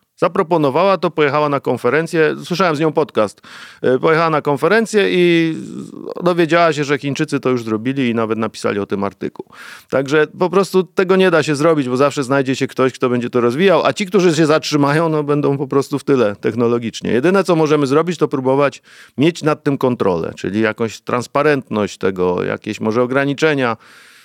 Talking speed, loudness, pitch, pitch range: 180 wpm, -16 LUFS, 145 Hz, 130-165 Hz